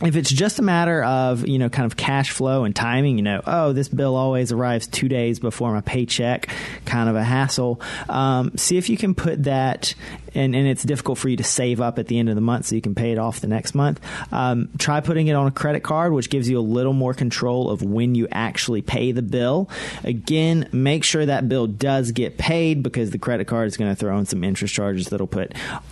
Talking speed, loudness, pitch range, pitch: 245 wpm, -21 LUFS, 115-140 Hz, 125 Hz